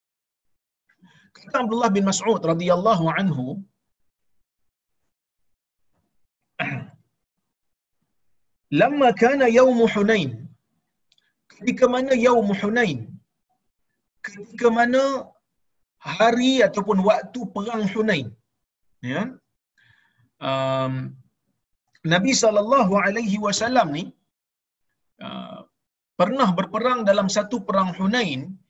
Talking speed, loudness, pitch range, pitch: 75 wpm, -21 LUFS, 175-235 Hz, 205 Hz